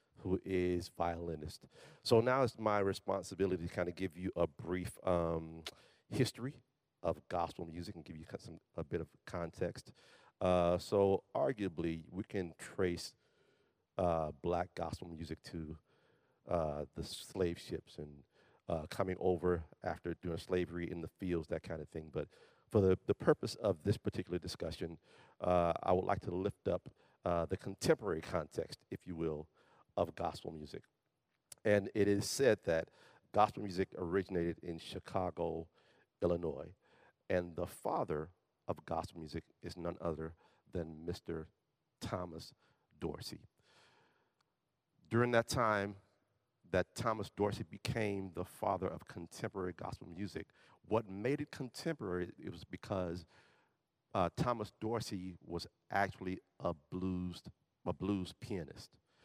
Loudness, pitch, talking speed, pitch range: -39 LUFS, 90 Hz, 140 wpm, 85-100 Hz